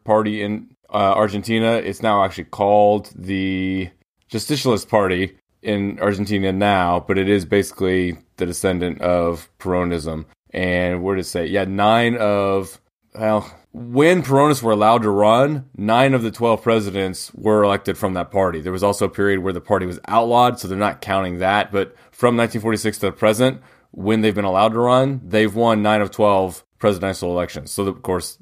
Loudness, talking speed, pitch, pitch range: -19 LUFS, 180 wpm, 100 Hz, 95-110 Hz